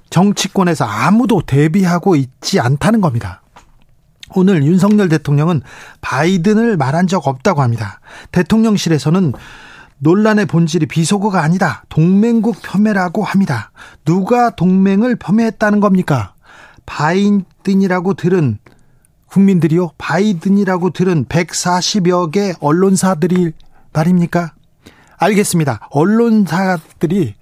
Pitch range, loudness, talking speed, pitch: 160-200 Hz, -14 LUFS, 280 characters per minute, 180 Hz